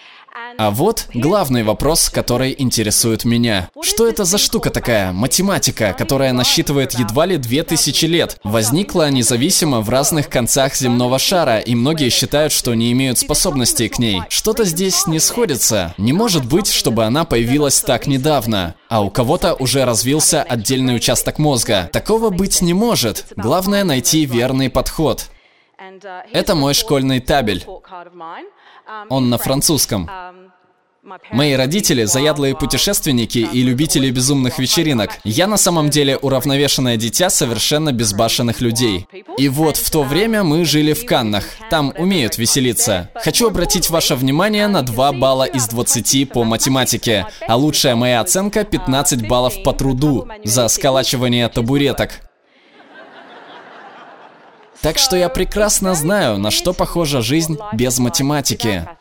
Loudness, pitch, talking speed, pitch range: -15 LUFS, 140 Hz, 135 wpm, 120-170 Hz